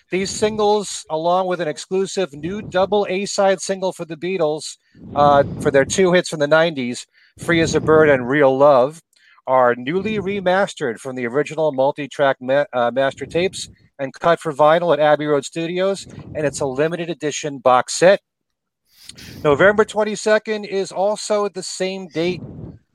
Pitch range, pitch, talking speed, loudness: 140-190 Hz, 160 Hz, 165 wpm, -18 LUFS